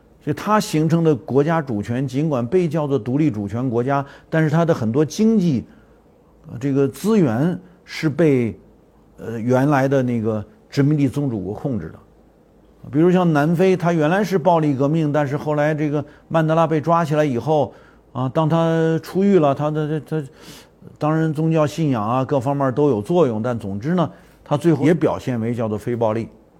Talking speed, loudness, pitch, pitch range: 270 characters per minute, -19 LUFS, 150 Hz, 130-165 Hz